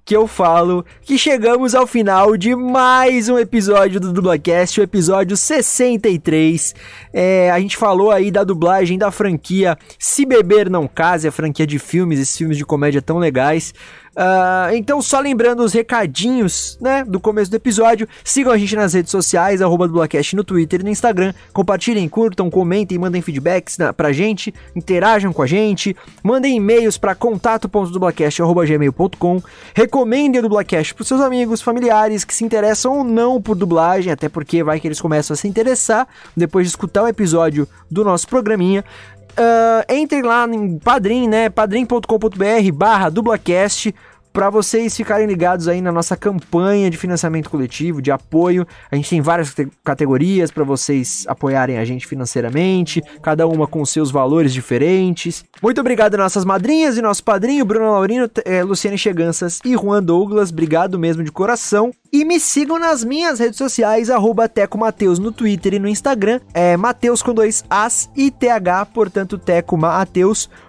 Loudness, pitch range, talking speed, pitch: -15 LUFS, 170-225 Hz, 160 wpm, 195 Hz